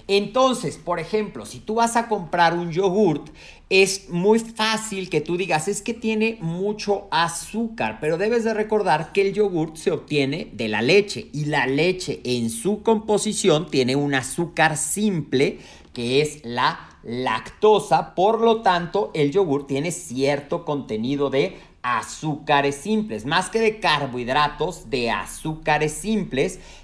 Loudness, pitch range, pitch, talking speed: -22 LUFS, 145-210 Hz, 170 Hz, 145 wpm